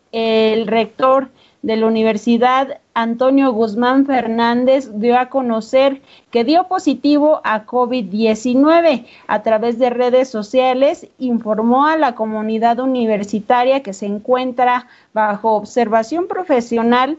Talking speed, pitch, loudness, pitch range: 110 wpm, 245 Hz, -16 LUFS, 225-265 Hz